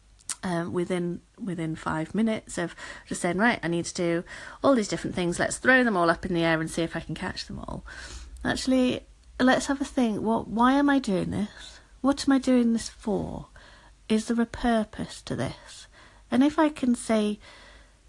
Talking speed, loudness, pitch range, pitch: 200 wpm, -26 LUFS, 170-250 Hz, 215 Hz